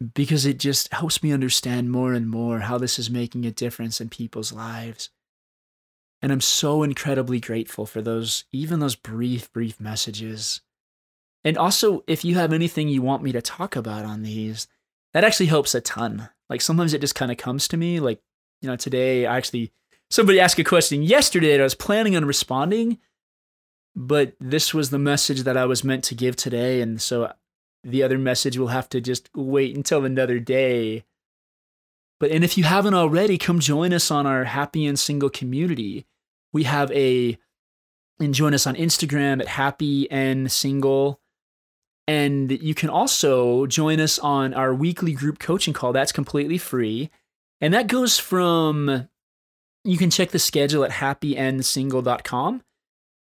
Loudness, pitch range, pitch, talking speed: -21 LUFS, 125-155 Hz, 135 Hz, 175 wpm